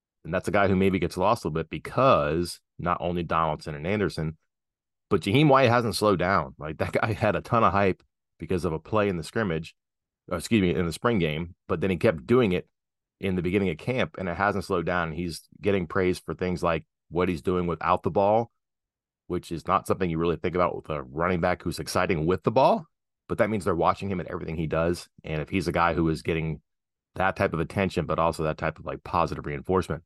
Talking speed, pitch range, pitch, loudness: 240 wpm, 80-95 Hz, 90 Hz, -26 LUFS